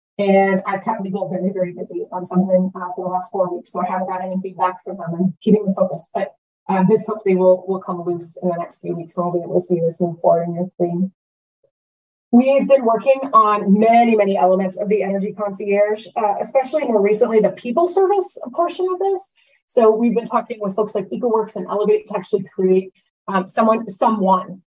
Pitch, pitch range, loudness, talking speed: 195 Hz, 185-220 Hz, -18 LUFS, 220 wpm